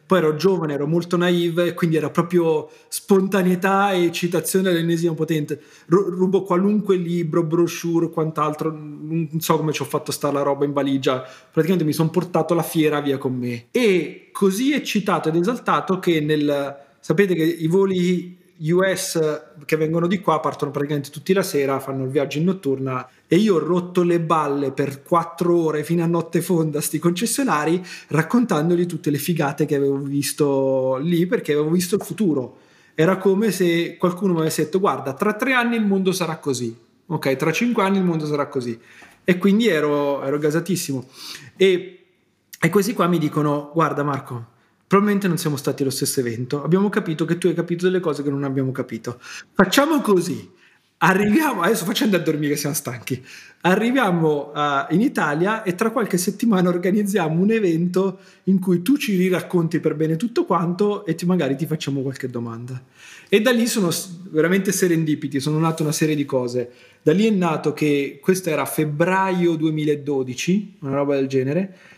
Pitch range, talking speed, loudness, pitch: 145-185 Hz, 175 wpm, -20 LUFS, 165 Hz